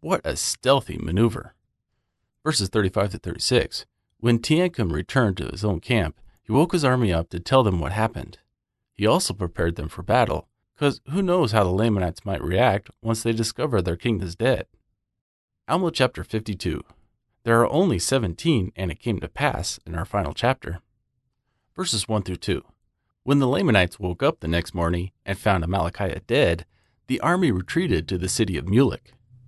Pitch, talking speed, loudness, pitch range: 110 Hz, 175 wpm, -23 LUFS, 90-125 Hz